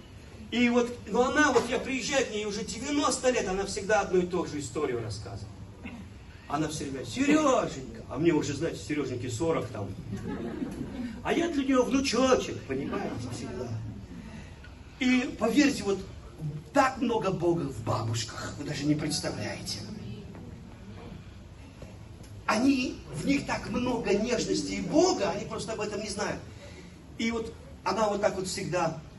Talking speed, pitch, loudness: 150 wpm, 165 Hz, -29 LUFS